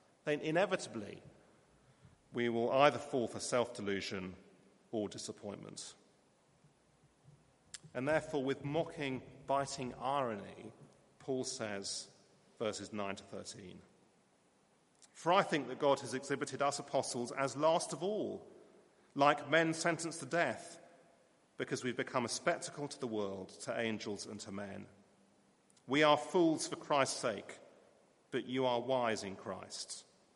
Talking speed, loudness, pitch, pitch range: 130 wpm, -37 LUFS, 130 Hz, 110-150 Hz